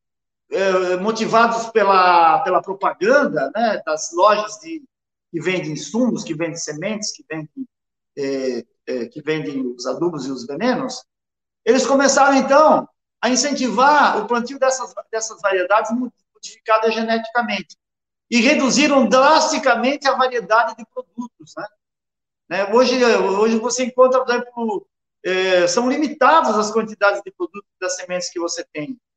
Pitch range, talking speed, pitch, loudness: 180-255 Hz, 130 wpm, 225 Hz, -18 LUFS